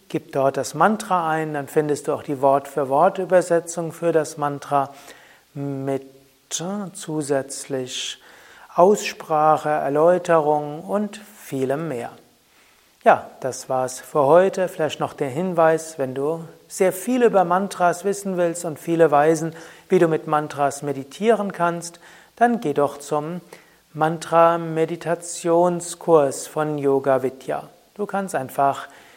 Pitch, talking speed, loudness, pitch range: 160 Hz, 130 wpm, -21 LUFS, 140-175 Hz